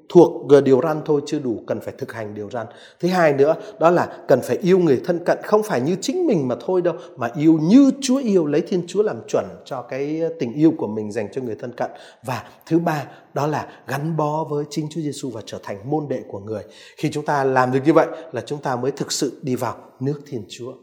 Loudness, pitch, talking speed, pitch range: -20 LUFS, 155 Hz, 255 wpm, 135-170 Hz